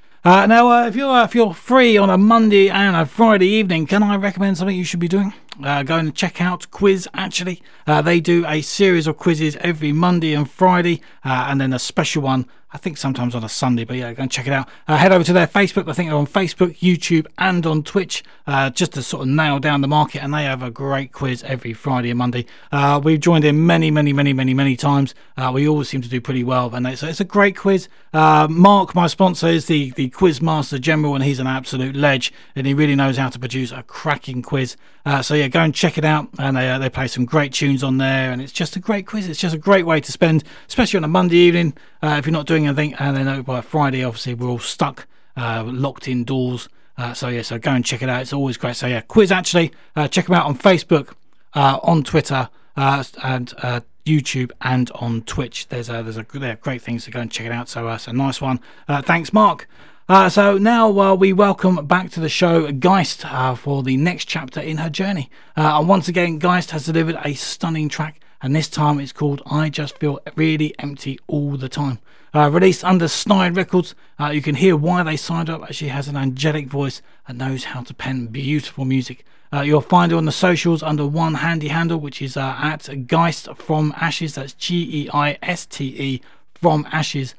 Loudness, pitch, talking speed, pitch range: -18 LUFS, 150 Hz, 235 wpm, 135-175 Hz